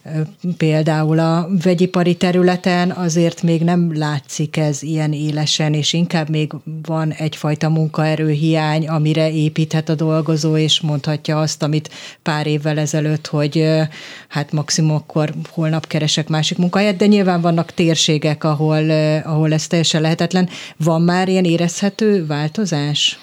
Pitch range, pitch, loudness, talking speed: 155-170 Hz, 160 Hz, -17 LUFS, 130 wpm